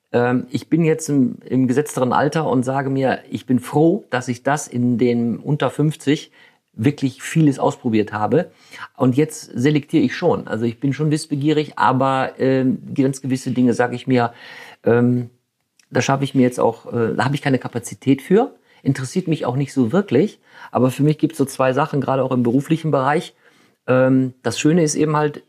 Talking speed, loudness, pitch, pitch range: 190 wpm, -19 LUFS, 135 Hz, 125-150 Hz